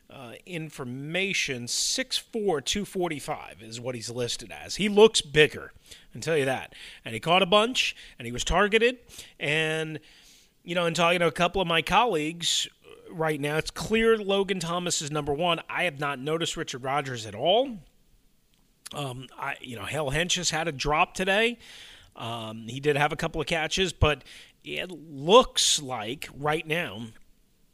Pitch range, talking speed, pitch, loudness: 140-180 Hz, 175 wpm, 160 Hz, -26 LUFS